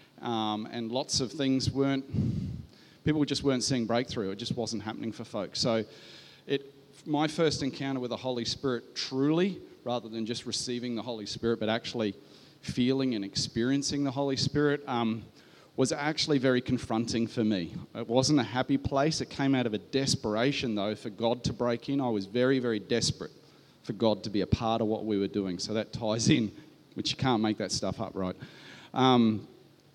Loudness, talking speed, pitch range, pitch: -30 LUFS, 190 wpm, 110-135 Hz, 120 Hz